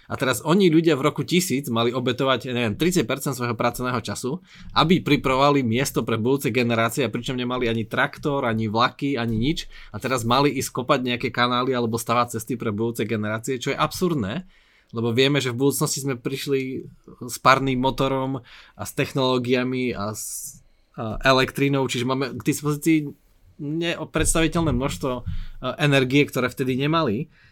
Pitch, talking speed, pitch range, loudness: 130 Hz, 155 wpm, 120-145 Hz, -22 LUFS